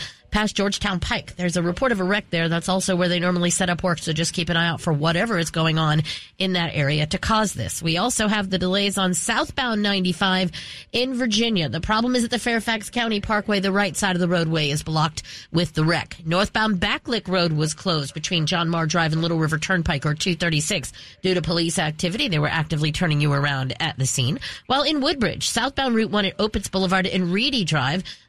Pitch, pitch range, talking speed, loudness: 180 Hz, 160-205 Hz, 220 wpm, -22 LUFS